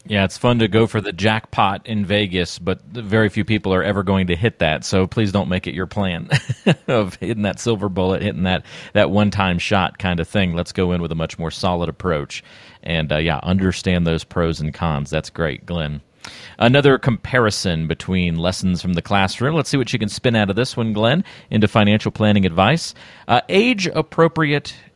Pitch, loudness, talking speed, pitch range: 100 Hz, -19 LUFS, 205 wpm, 90-110 Hz